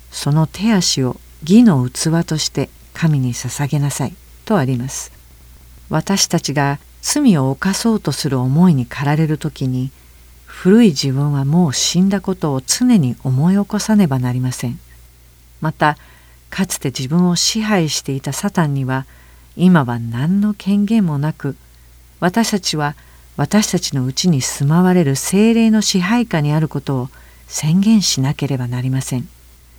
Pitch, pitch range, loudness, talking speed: 145 Hz, 130-180 Hz, -16 LUFS, 285 characters per minute